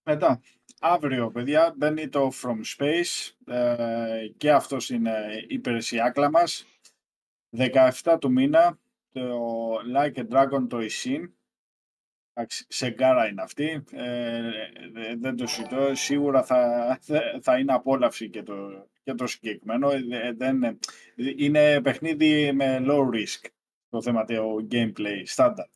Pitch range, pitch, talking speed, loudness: 115-145 Hz, 130 Hz, 120 wpm, -25 LUFS